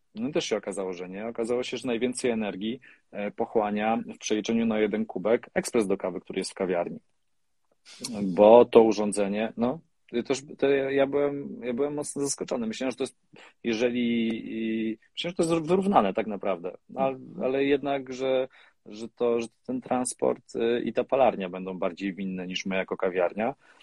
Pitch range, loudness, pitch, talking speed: 110-135 Hz, -27 LUFS, 120 Hz, 170 wpm